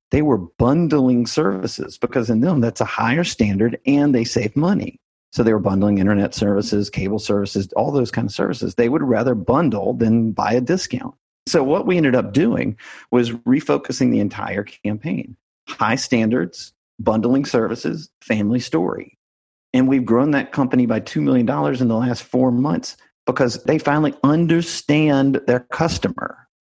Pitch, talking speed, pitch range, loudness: 120 Hz, 160 wpm, 105-135 Hz, -19 LUFS